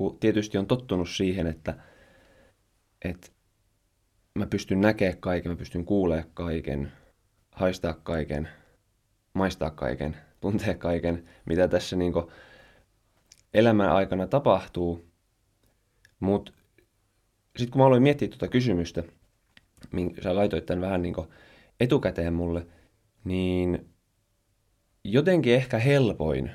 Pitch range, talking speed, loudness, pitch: 85-110 Hz, 100 wpm, -27 LUFS, 95 Hz